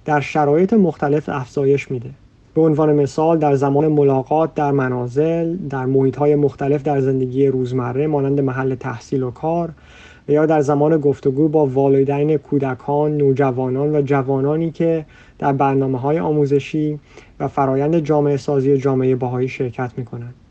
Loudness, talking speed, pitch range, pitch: -18 LUFS, 145 wpm, 135-150 Hz, 140 Hz